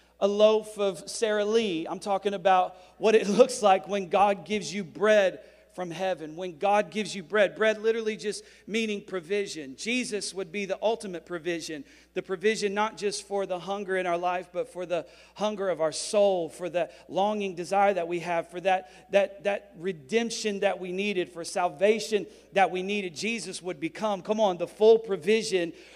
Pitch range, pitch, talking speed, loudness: 180-210 Hz, 200 Hz, 185 wpm, -27 LUFS